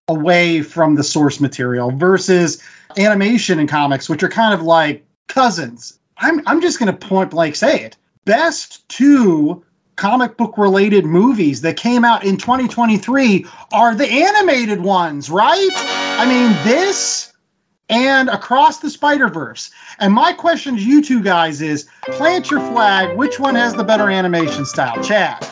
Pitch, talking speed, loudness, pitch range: 205 Hz, 155 wpm, -14 LUFS, 165-260 Hz